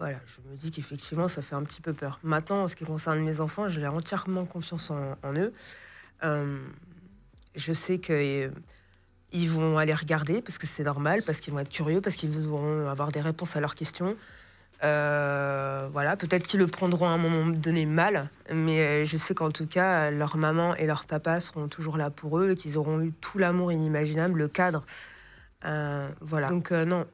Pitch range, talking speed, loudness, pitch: 145-175 Hz, 200 wpm, -29 LUFS, 155 Hz